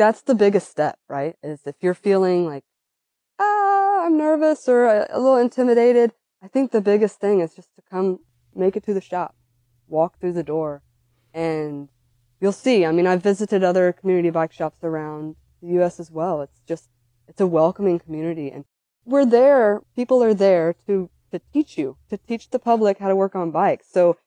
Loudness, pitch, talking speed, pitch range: -20 LUFS, 185 Hz, 190 wpm, 160-220 Hz